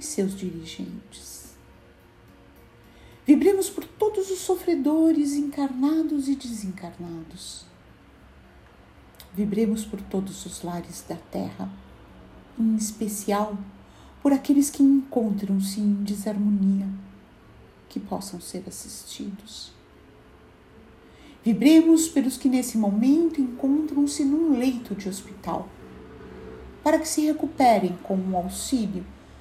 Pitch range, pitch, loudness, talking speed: 180-285 Hz, 210 Hz, -24 LUFS, 100 wpm